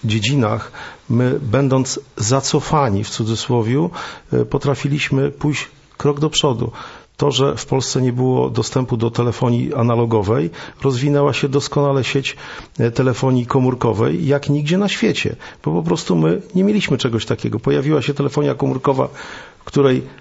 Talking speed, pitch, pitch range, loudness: 130 wpm, 135 Hz, 120-145 Hz, -18 LUFS